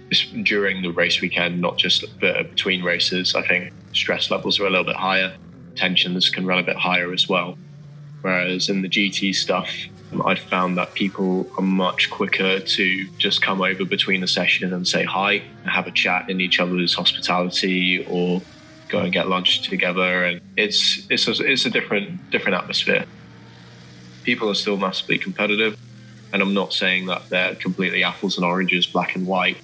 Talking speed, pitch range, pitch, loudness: 180 wpm, 90-95 Hz, 95 Hz, -20 LUFS